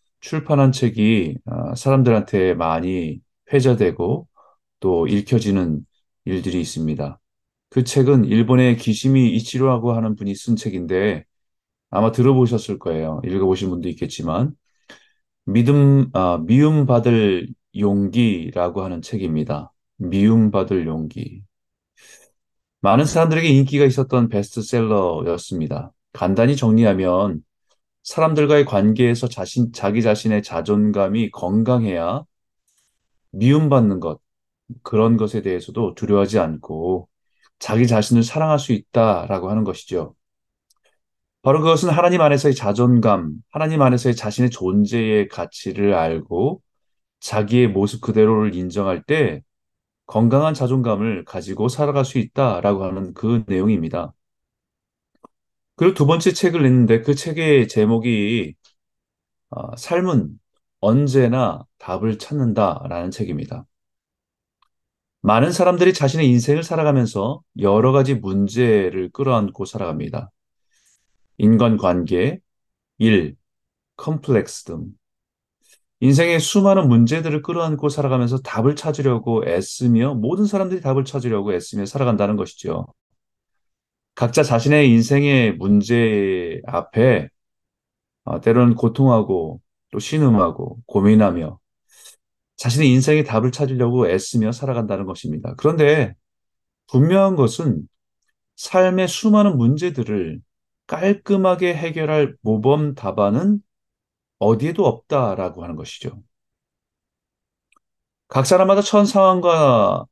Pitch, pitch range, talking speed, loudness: 120 Hz, 105-140 Hz, 265 characters per minute, -18 LUFS